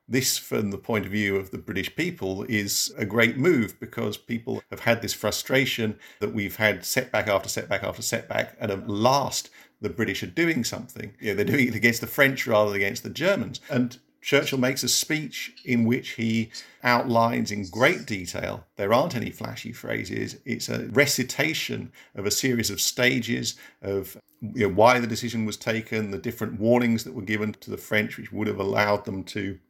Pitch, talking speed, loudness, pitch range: 115 Hz, 195 wpm, -25 LUFS, 105-125 Hz